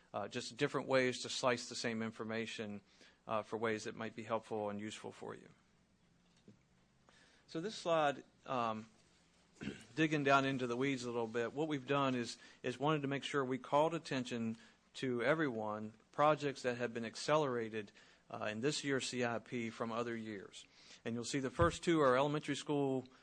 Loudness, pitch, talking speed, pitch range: -38 LUFS, 125 Hz, 175 wpm, 115-140 Hz